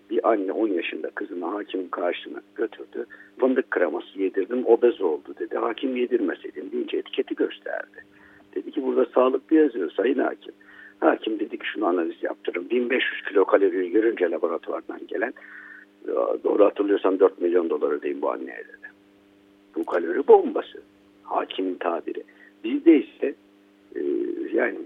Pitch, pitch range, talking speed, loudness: 365 Hz, 335-420 Hz, 135 wpm, -24 LUFS